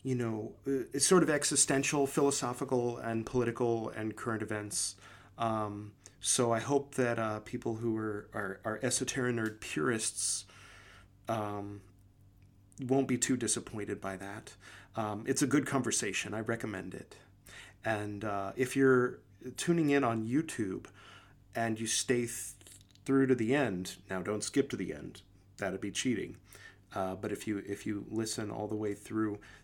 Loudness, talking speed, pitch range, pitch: -33 LUFS, 155 wpm, 100-125 Hz, 110 Hz